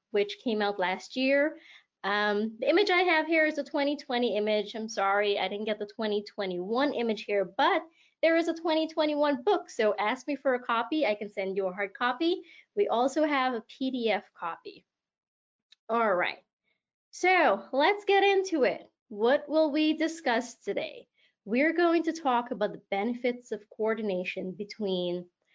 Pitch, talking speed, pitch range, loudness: 245 Hz, 165 wpm, 210-310 Hz, -28 LUFS